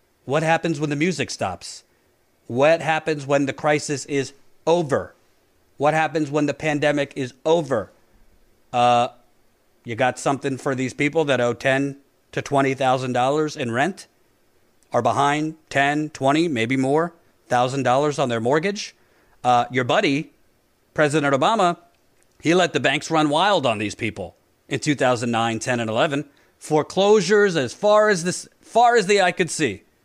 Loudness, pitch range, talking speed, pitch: -21 LUFS, 130-160 Hz, 145 wpm, 145 Hz